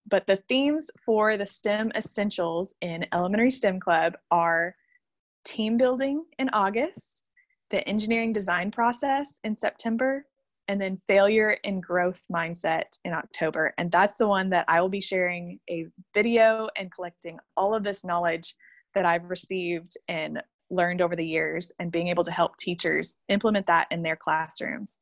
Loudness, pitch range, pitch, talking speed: -26 LUFS, 175-220 Hz, 195 Hz, 160 wpm